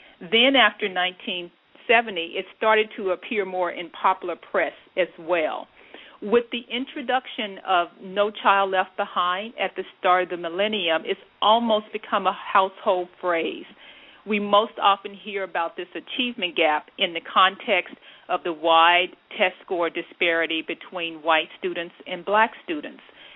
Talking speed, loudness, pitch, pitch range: 145 wpm, -23 LUFS, 190 Hz, 175-215 Hz